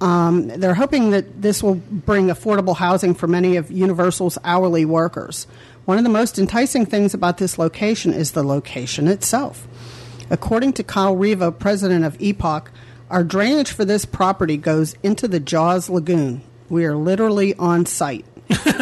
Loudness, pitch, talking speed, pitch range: -18 LUFS, 180 Hz, 160 wpm, 165-200 Hz